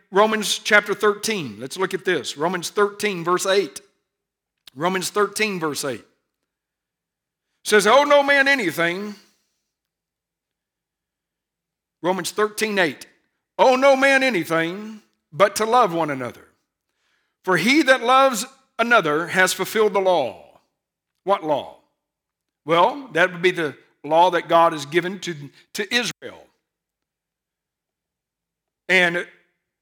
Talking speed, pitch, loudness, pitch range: 115 wpm, 195 Hz, -19 LUFS, 170-215 Hz